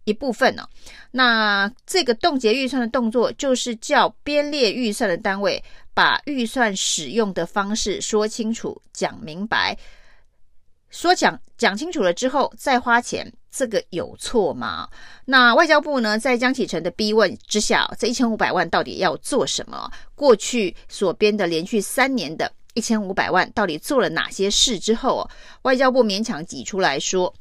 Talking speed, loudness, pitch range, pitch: 250 characters per minute, -20 LUFS, 210-260 Hz, 235 Hz